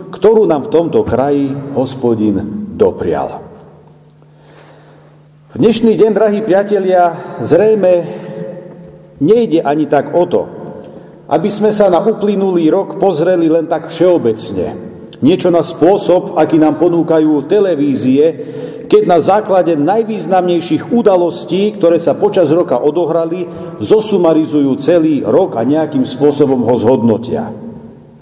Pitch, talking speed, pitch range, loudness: 170 Hz, 115 wpm, 150-200 Hz, -12 LUFS